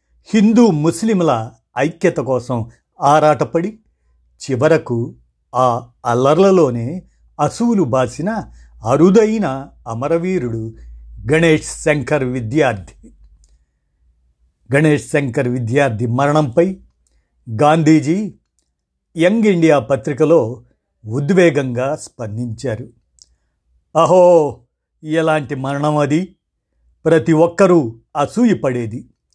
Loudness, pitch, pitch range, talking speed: -15 LUFS, 140 Hz, 115-165 Hz, 65 wpm